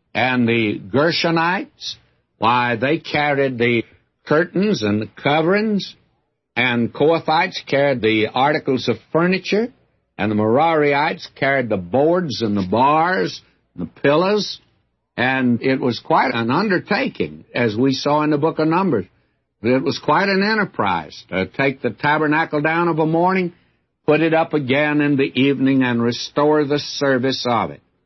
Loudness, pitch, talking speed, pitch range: -18 LUFS, 140 Hz, 150 wpm, 120-160 Hz